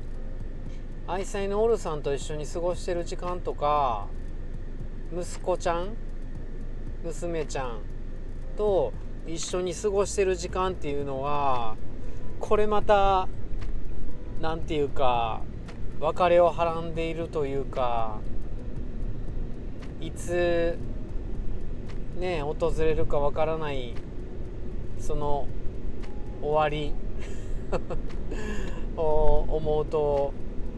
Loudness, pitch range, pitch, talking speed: -29 LUFS, 120-165 Hz, 140 Hz, 175 characters per minute